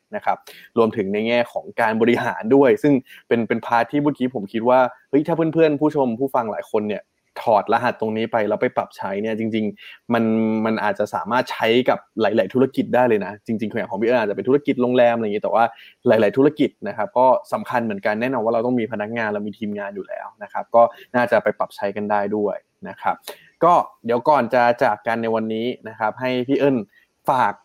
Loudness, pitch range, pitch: -20 LUFS, 110-125 Hz, 115 Hz